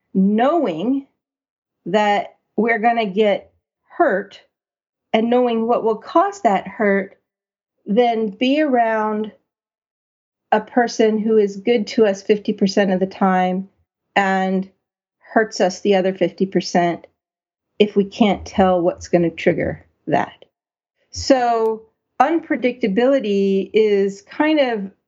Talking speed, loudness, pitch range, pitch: 115 wpm, -18 LUFS, 195-235 Hz, 215 Hz